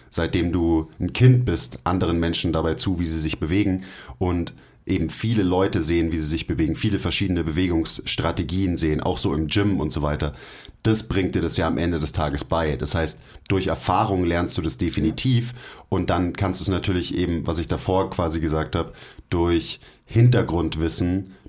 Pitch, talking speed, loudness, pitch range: 85 Hz, 185 wpm, -23 LUFS, 80-95 Hz